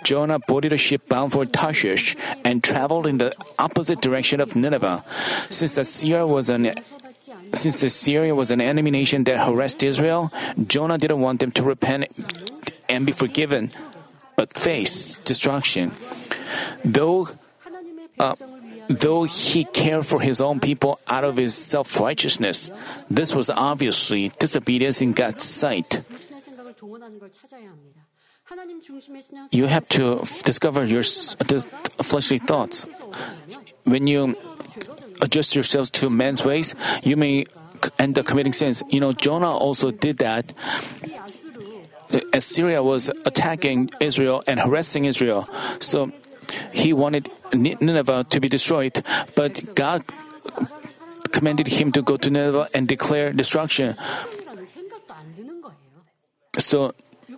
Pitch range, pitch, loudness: 135-175 Hz, 145 Hz, -20 LUFS